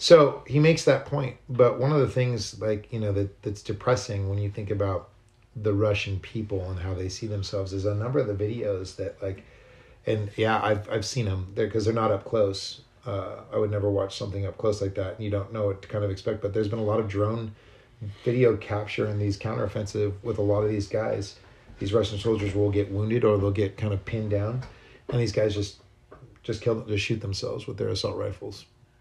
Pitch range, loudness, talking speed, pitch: 100-115 Hz, -27 LUFS, 230 wpm, 105 Hz